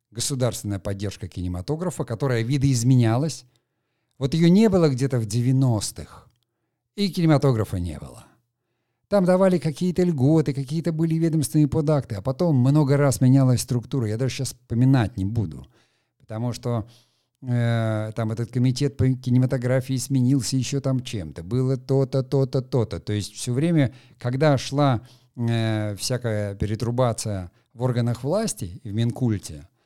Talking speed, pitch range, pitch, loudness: 135 wpm, 115-140 Hz, 125 Hz, -23 LUFS